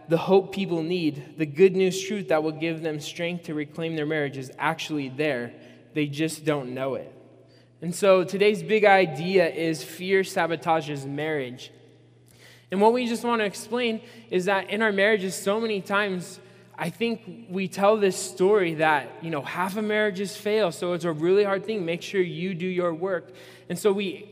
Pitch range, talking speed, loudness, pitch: 155-195 Hz, 190 wpm, -25 LUFS, 180 Hz